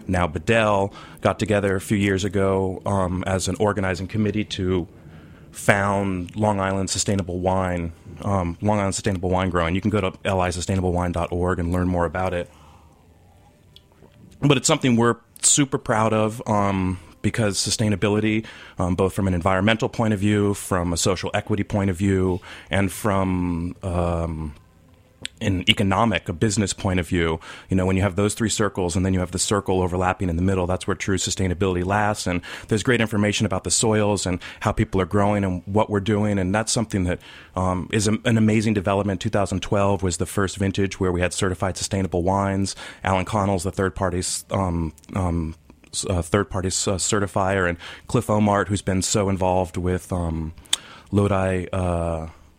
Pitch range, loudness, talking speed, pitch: 90-105 Hz, -22 LUFS, 175 wpm, 95 Hz